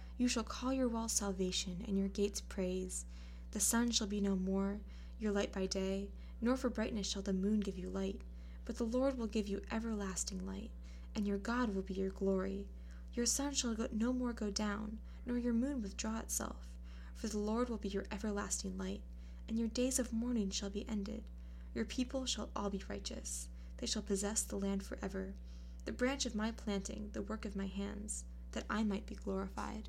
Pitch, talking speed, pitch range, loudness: 200 Hz, 200 wpm, 190-225 Hz, -39 LUFS